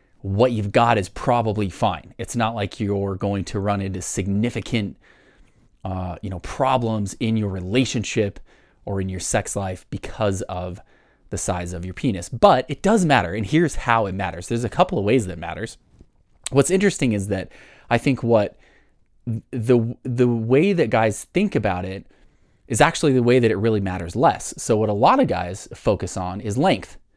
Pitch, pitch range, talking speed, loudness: 110 Hz, 95-120 Hz, 190 wpm, -21 LUFS